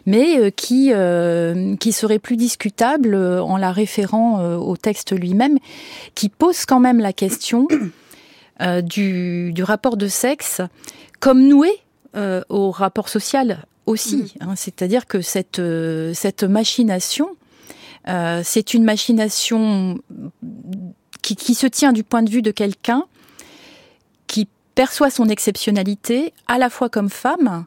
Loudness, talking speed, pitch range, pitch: -18 LUFS, 130 wpm, 190-250 Hz, 215 Hz